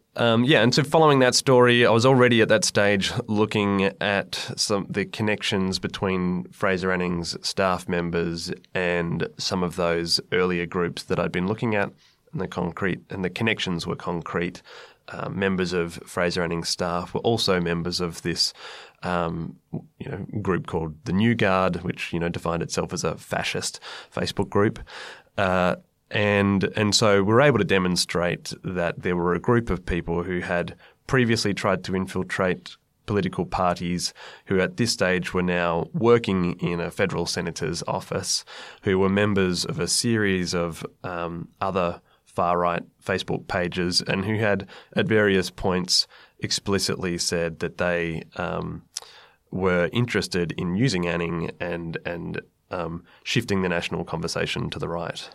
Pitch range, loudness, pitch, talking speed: 85-105 Hz, -24 LUFS, 90 Hz, 160 wpm